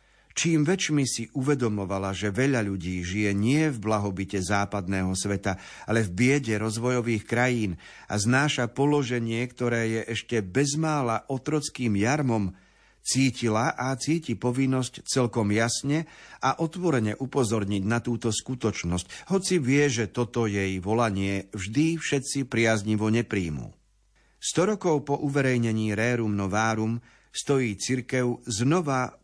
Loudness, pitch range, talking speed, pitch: -26 LUFS, 105-135 Hz, 120 wpm, 120 Hz